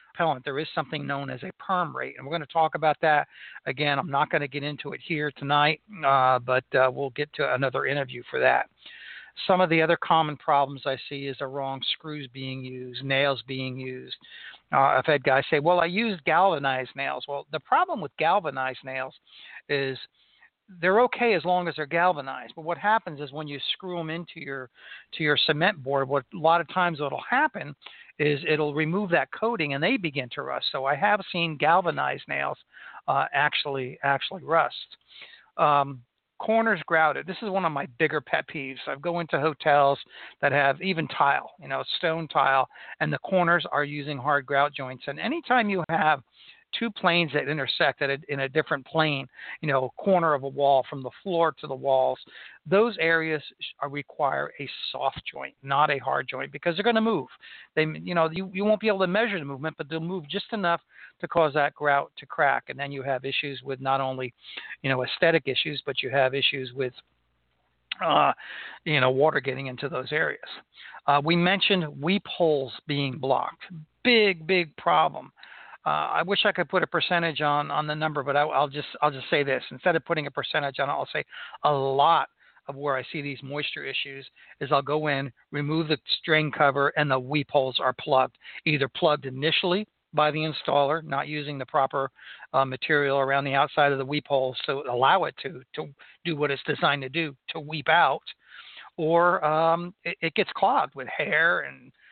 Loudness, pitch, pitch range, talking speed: -25 LUFS, 150 Hz, 135-170 Hz, 200 wpm